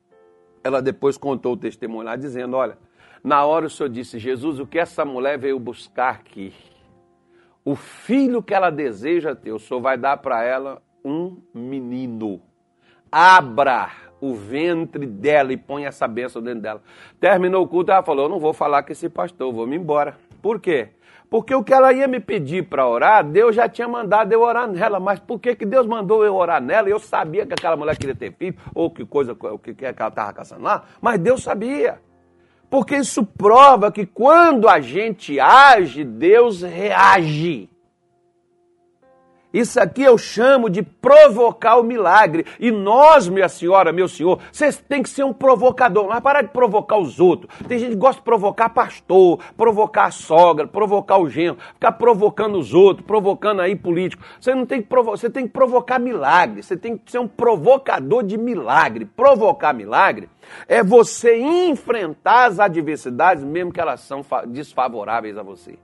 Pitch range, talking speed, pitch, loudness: 145-240 Hz, 175 wpm, 190 Hz, -16 LUFS